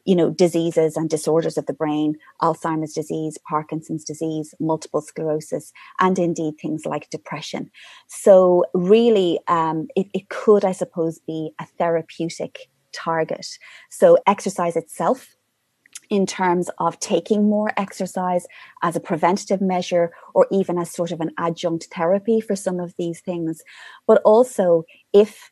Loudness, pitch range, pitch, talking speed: -21 LUFS, 160-190 Hz, 170 Hz, 140 wpm